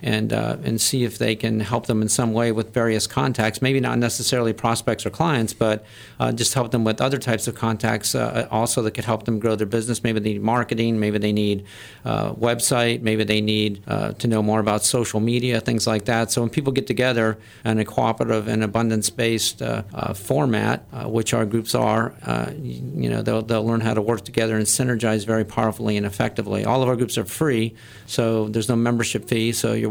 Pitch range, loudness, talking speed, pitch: 110-120 Hz, -22 LUFS, 220 wpm, 115 Hz